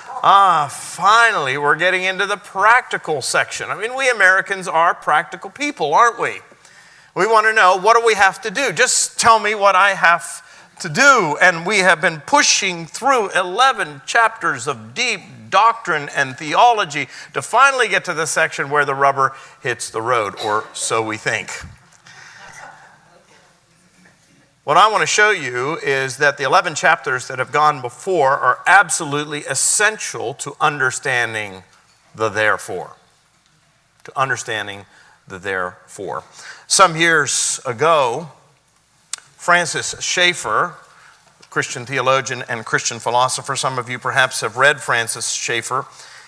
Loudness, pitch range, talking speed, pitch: -16 LUFS, 140-205 Hz, 140 wpm, 175 Hz